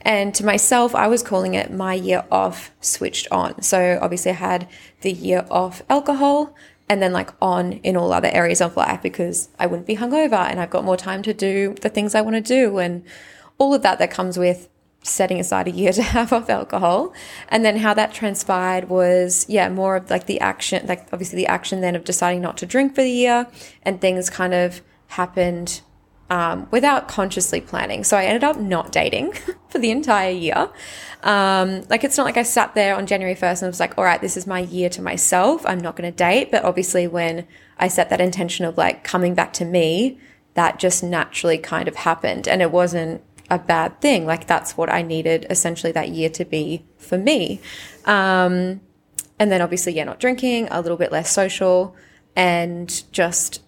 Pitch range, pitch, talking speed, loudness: 175-210 Hz, 185 Hz, 210 wpm, -19 LUFS